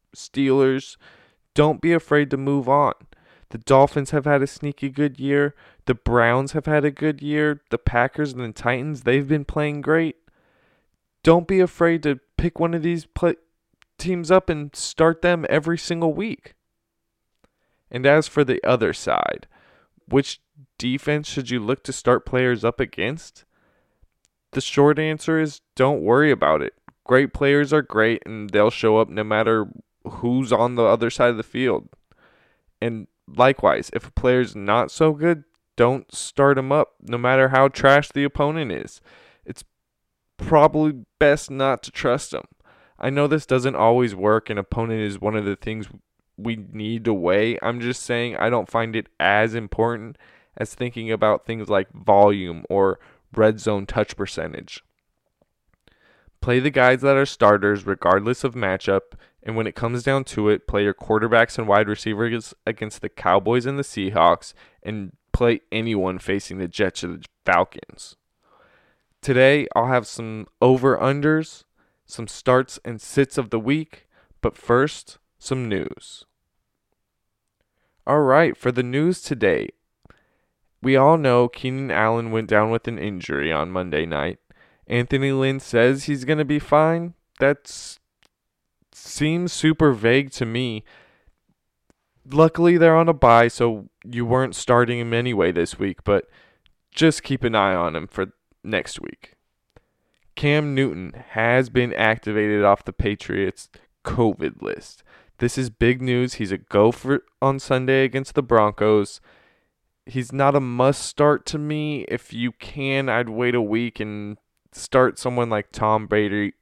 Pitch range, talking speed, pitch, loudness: 110-145 Hz, 155 wpm, 125 Hz, -21 LUFS